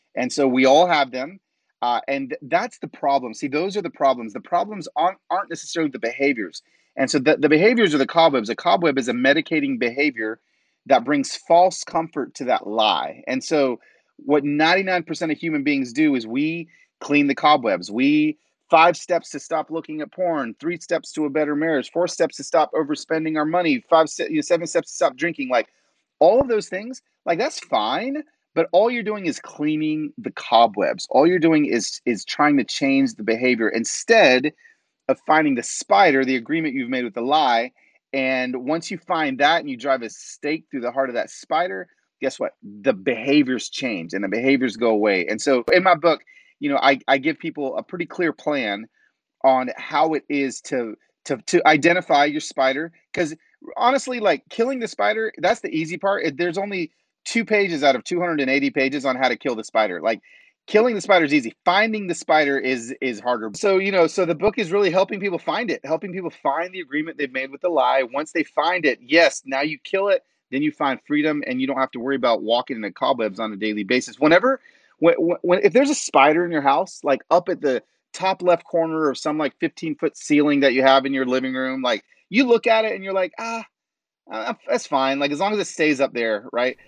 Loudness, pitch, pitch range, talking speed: -21 LUFS, 160 Hz, 135-195 Hz, 215 wpm